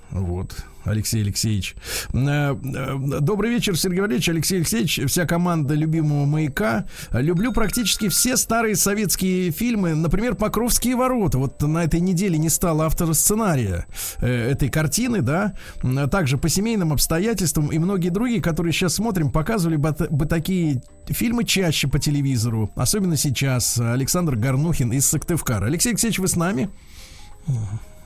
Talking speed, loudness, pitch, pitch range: 135 wpm, -21 LUFS, 160 Hz, 135-195 Hz